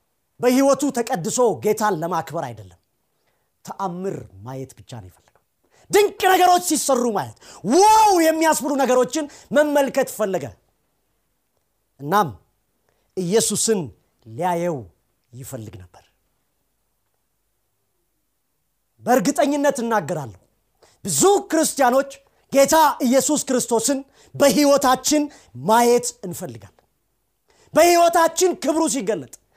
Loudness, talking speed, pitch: -19 LUFS, 75 wpm, 220 Hz